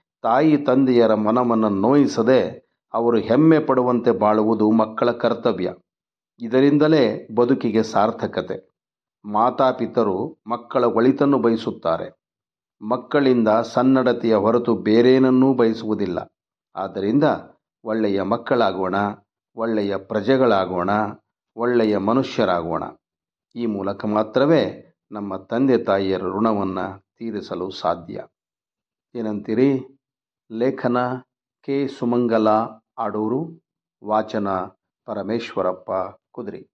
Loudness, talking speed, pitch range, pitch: -20 LUFS, 75 wpm, 105-130 Hz, 115 Hz